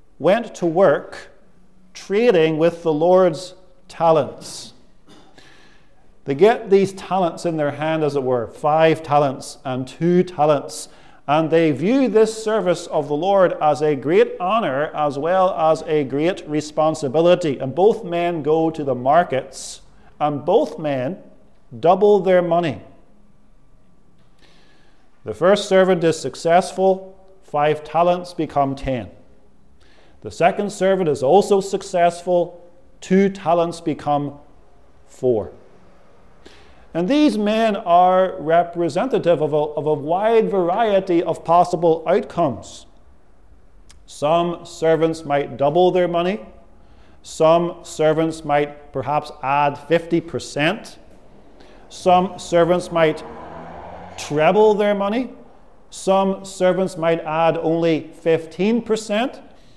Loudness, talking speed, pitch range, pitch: -19 LUFS, 110 wpm, 150-185 Hz, 170 Hz